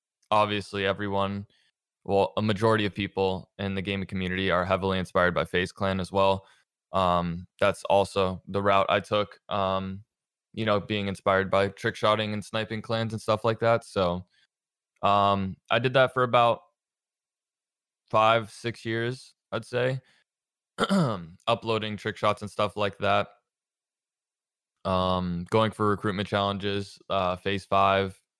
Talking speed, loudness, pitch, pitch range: 140 wpm, -27 LUFS, 100 Hz, 95-110 Hz